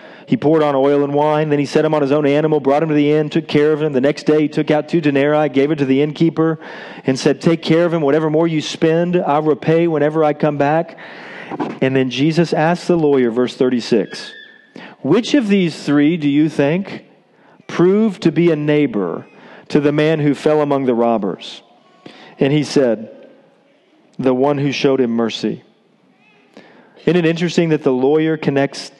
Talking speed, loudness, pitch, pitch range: 200 wpm, -16 LUFS, 150 Hz, 140-160 Hz